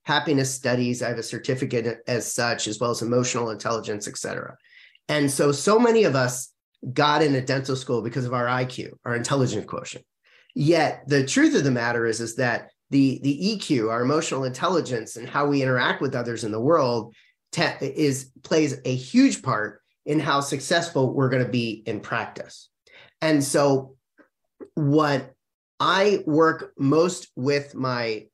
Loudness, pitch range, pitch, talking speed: -23 LUFS, 120-145 Hz, 130 Hz, 170 wpm